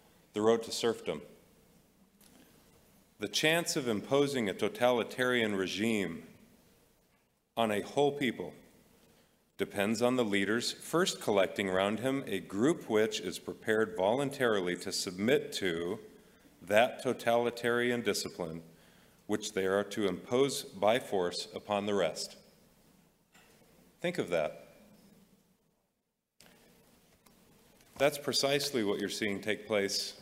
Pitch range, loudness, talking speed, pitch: 100-125 Hz, -32 LUFS, 110 wpm, 110 Hz